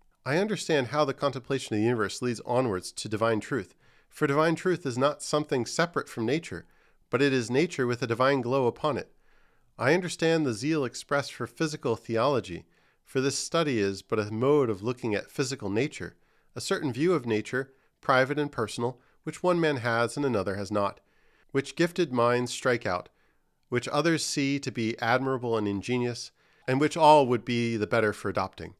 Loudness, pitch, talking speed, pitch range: -28 LUFS, 130 Hz, 190 wpm, 115-150 Hz